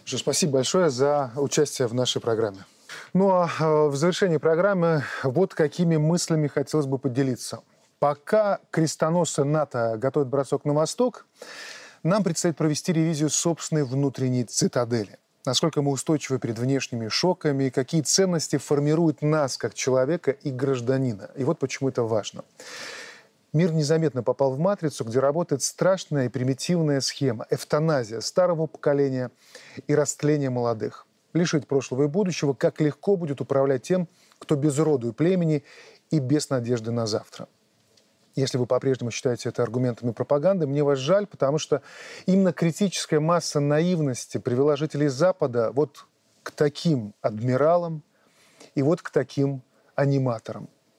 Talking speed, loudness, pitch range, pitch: 135 wpm, -24 LUFS, 130-160 Hz, 145 Hz